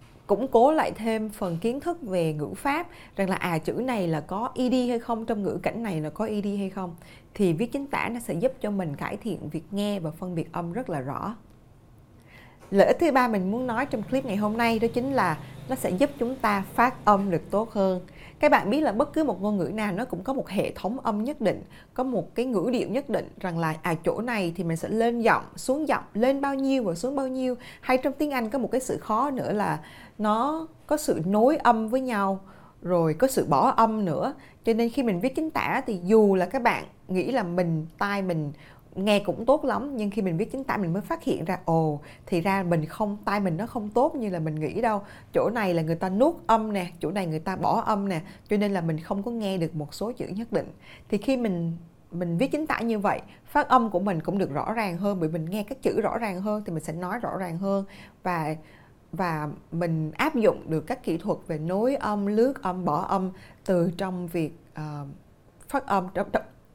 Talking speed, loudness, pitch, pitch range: 245 wpm, -26 LUFS, 200 Hz, 175-240 Hz